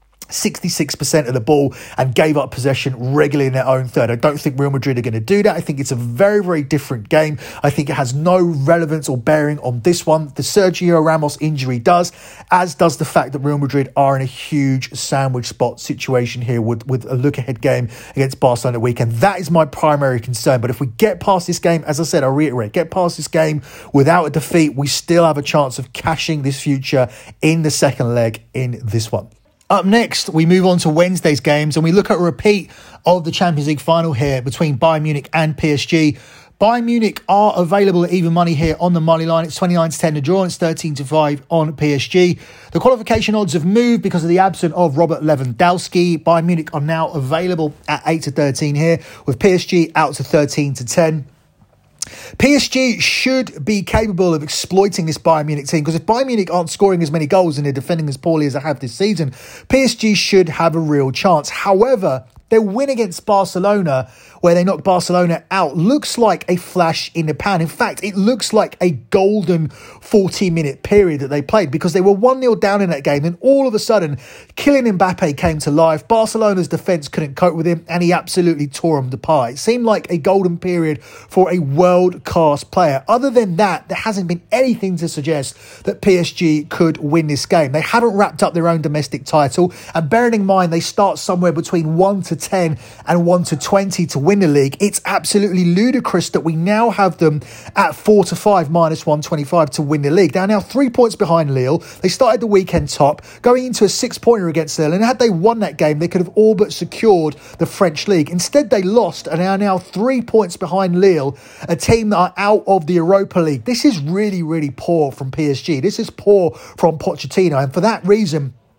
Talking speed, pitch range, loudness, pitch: 215 wpm, 145-190 Hz, -15 LUFS, 165 Hz